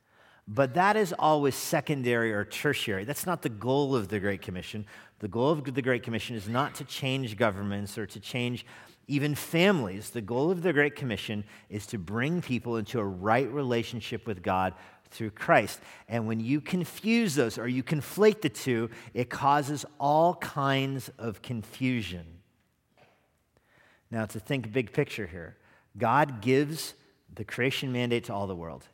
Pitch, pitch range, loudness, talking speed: 125 Hz, 110-145 Hz, -29 LUFS, 165 wpm